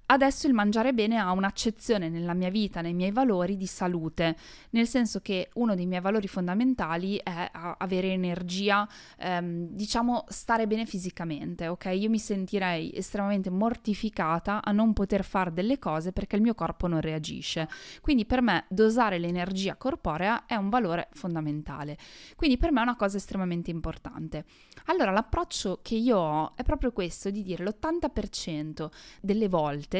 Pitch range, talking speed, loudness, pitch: 175-225 Hz, 160 wpm, -28 LUFS, 195 Hz